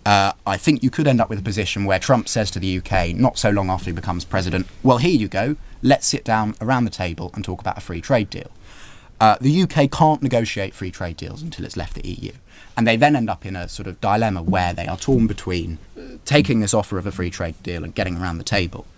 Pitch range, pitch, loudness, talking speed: 90-120 Hz, 100 Hz, -20 LUFS, 260 wpm